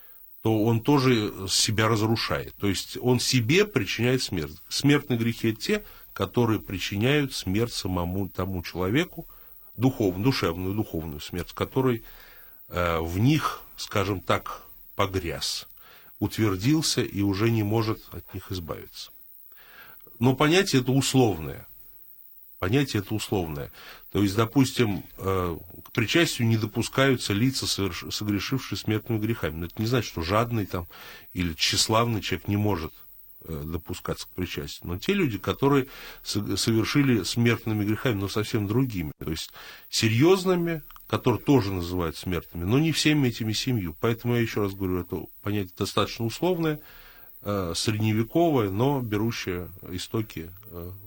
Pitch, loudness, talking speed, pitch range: 110 Hz, -26 LUFS, 125 wpm, 95-125 Hz